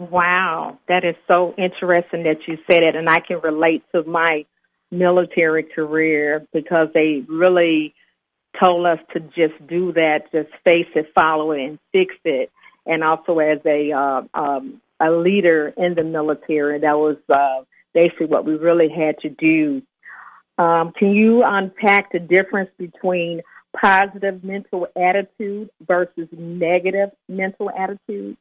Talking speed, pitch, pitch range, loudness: 145 wpm, 170 Hz, 155-190 Hz, -18 LUFS